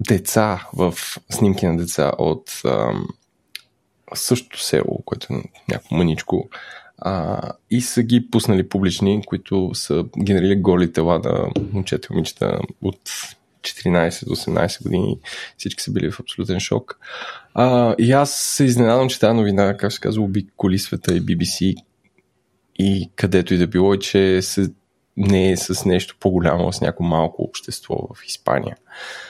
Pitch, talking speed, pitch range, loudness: 95 Hz, 145 wpm, 90-105 Hz, -20 LUFS